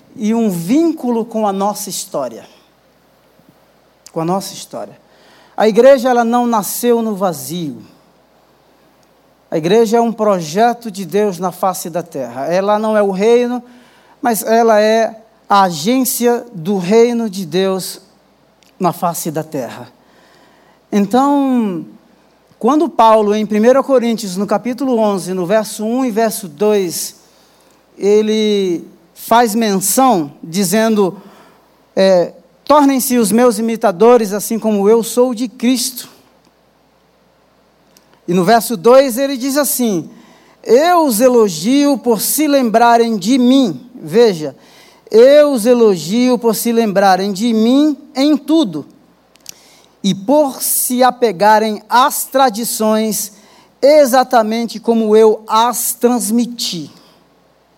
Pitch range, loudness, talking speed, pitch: 200-245 Hz, -13 LUFS, 120 wpm, 225 Hz